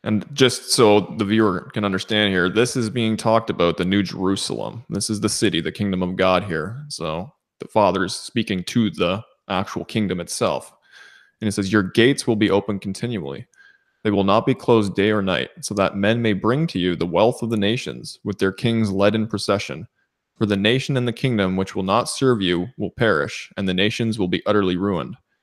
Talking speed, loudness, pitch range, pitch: 210 wpm, -21 LUFS, 95-115 Hz, 105 Hz